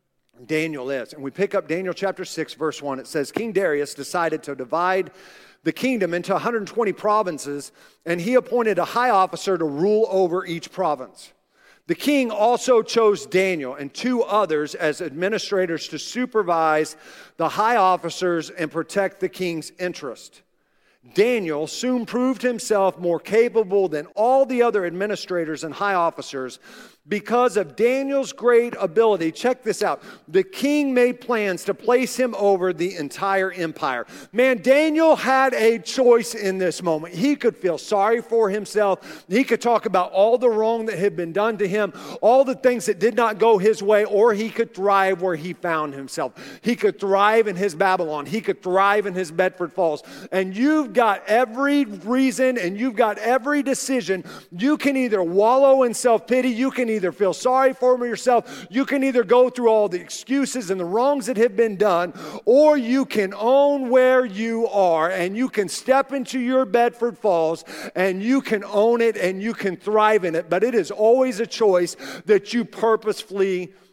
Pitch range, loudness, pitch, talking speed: 180-245 Hz, -21 LUFS, 210 Hz, 175 wpm